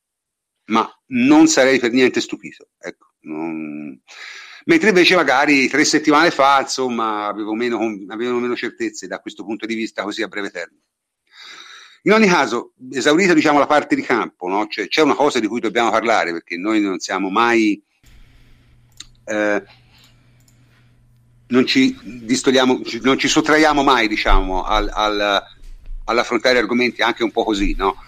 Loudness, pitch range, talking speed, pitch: -17 LUFS, 115-170 Hz, 150 wpm, 125 Hz